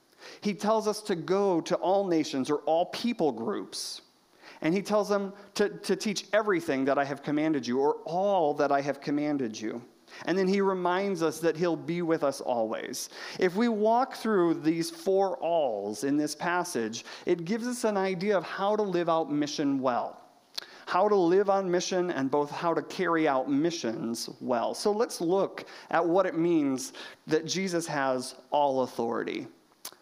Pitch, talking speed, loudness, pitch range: 170 Hz, 180 wpm, -28 LUFS, 145-195 Hz